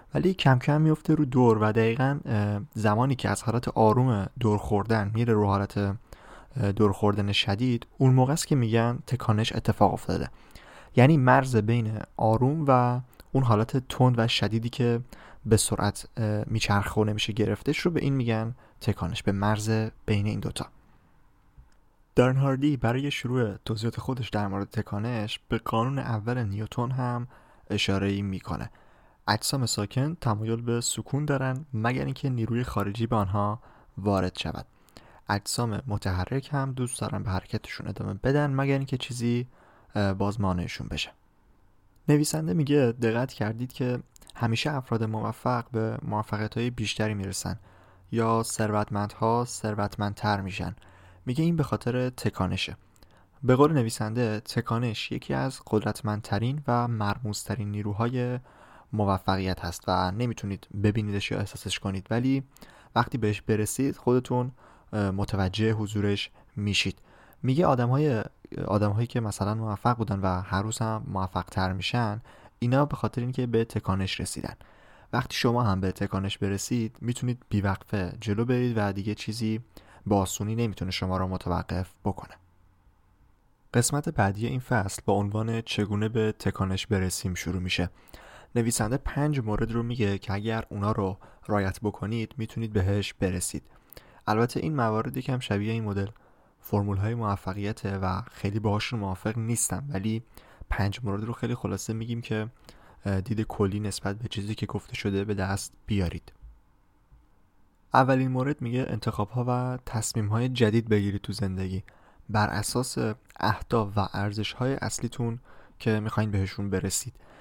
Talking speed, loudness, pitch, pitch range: 140 wpm, -28 LUFS, 110 Hz, 100-120 Hz